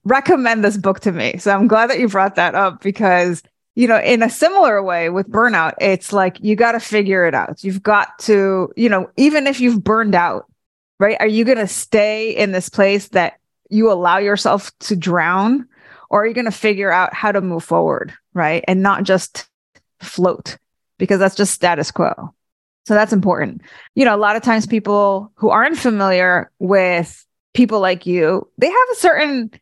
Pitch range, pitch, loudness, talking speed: 185-230 Hz, 205 Hz, -15 LUFS, 195 wpm